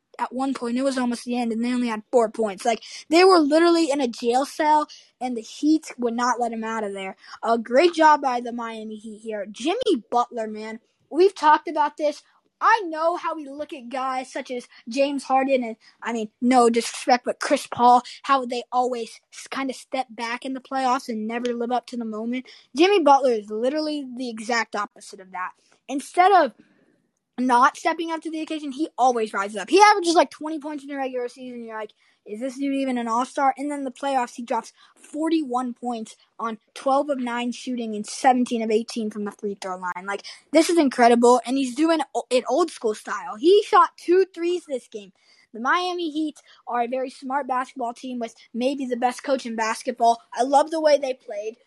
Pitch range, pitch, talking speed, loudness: 230-295 Hz, 255 Hz, 215 wpm, -23 LUFS